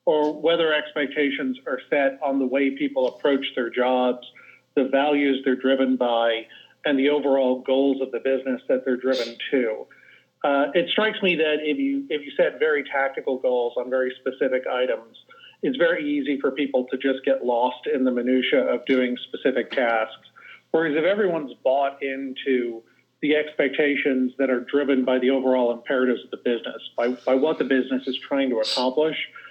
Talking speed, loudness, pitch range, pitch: 175 wpm, -23 LUFS, 130-150 Hz, 135 Hz